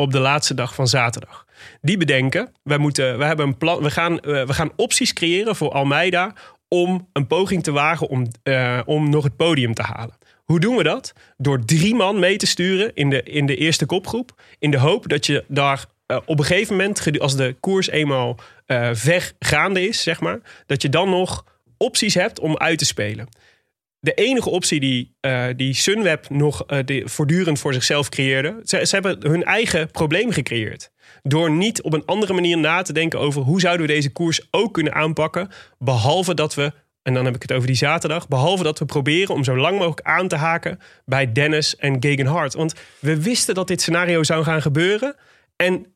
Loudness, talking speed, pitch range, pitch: -19 LUFS, 205 wpm, 135-175 Hz, 155 Hz